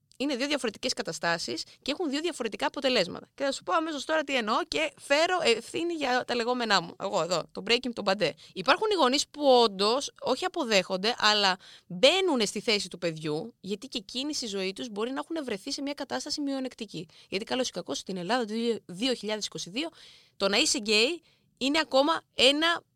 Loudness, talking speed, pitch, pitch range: -28 LUFS, 190 wpm, 250 Hz, 205-285 Hz